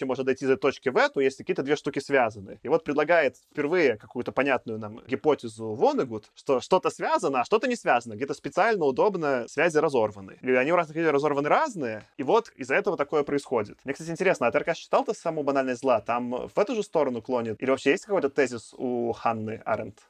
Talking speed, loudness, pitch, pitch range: 205 wpm, -26 LUFS, 140 Hz, 120-165 Hz